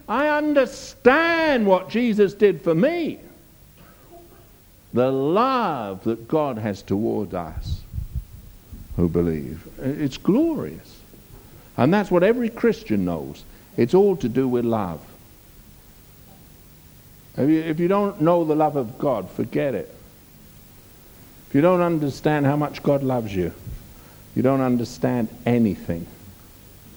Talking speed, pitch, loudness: 120 wpm, 125 Hz, -22 LUFS